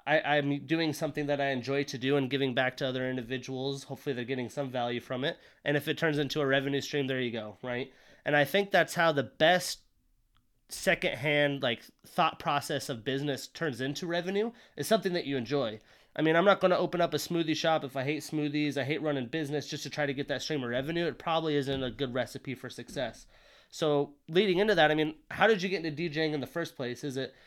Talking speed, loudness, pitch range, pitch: 240 wpm, -30 LUFS, 135-160 Hz, 145 Hz